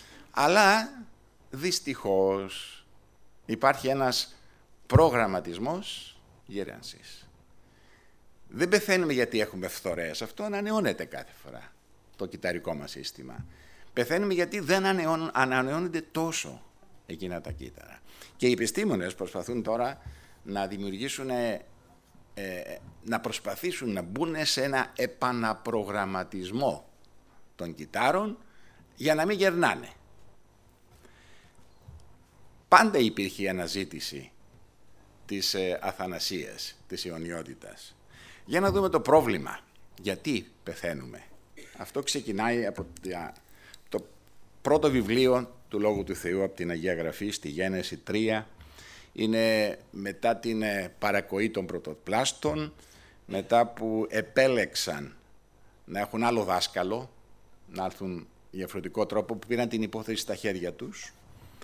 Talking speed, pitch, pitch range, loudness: 100 wpm, 110 Hz, 95-135 Hz, -29 LUFS